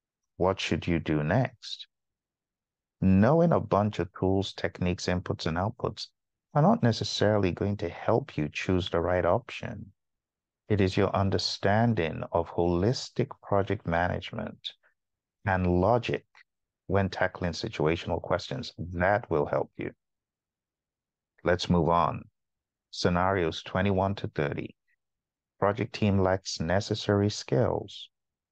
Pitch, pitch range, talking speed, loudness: 95 Hz, 85-105 Hz, 115 wpm, -28 LUFS